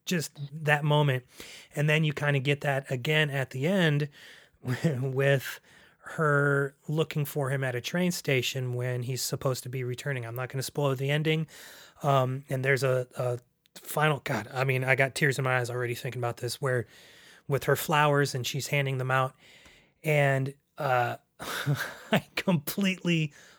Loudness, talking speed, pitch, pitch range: -28 LUFS, 170 wpm, 140 Hz, 130-150 Hz